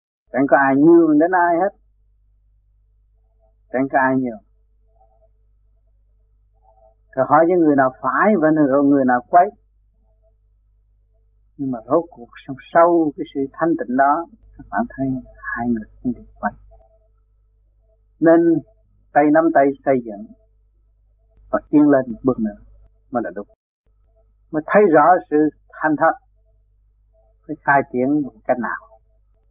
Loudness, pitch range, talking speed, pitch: -17 LUFS, 105-140 Hz, 140 wpm, 110 Hz